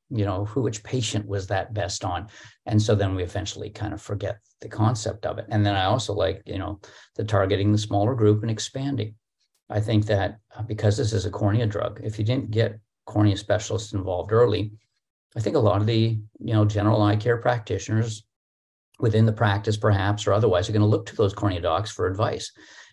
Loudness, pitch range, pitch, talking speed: -24 LUFS, 100-110 Hz, 105 Hz, 210 wpm